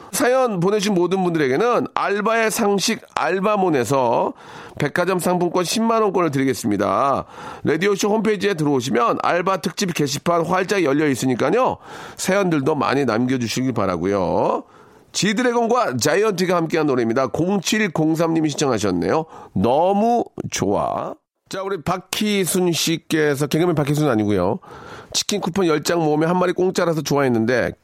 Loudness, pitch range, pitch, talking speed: -19 LUFS, 150-200 Hz, 180 Hz, 345 characters per minute